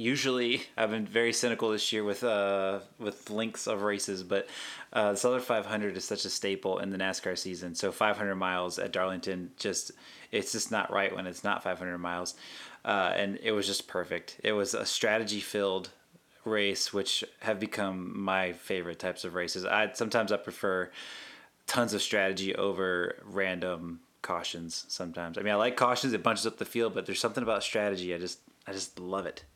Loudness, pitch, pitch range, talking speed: -31 LUFS, 100 Hz, 90-105 Hz, 195 wpm